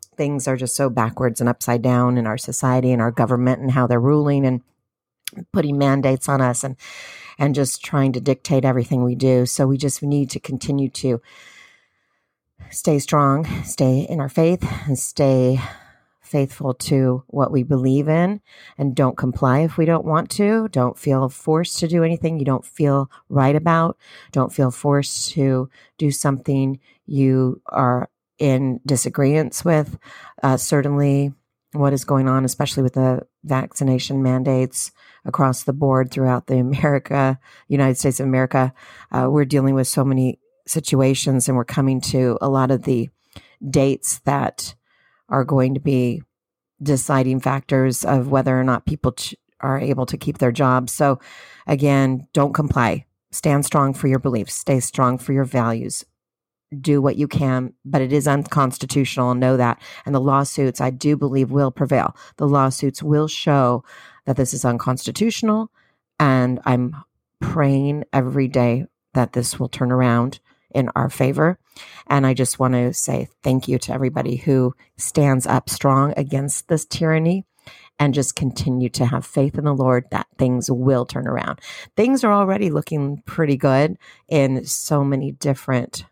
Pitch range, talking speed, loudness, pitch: 130-145 Hz, 160 wpm, -19 LUFS, 135 Hz